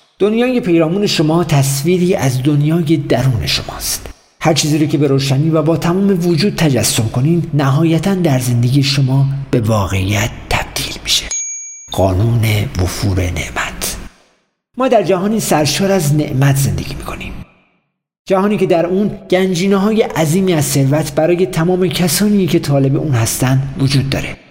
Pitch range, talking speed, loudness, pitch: 135-185 Hz, 140 wpm, -14 LUFS, 155 Hz